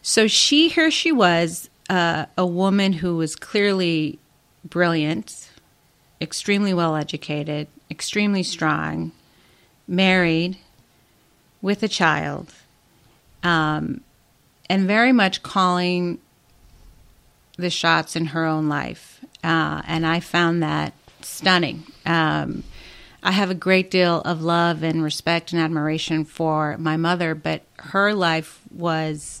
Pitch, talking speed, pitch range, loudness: 170 Hz, 115 wpm, 155-185 Hz, -21 LUFS